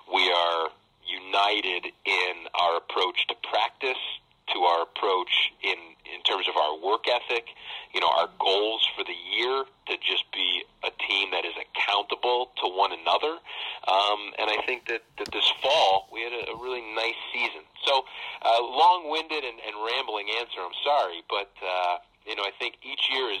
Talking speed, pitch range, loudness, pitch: 175 wpm, 95-125 Hz, -26 LUFS, 110 Hz